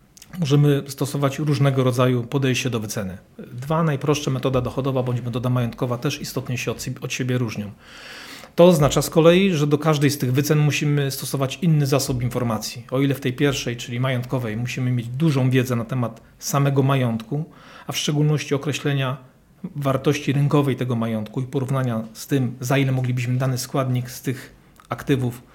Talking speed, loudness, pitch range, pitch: 170 wpm, -22 LUFS, 125-145 Hz, 135 Hz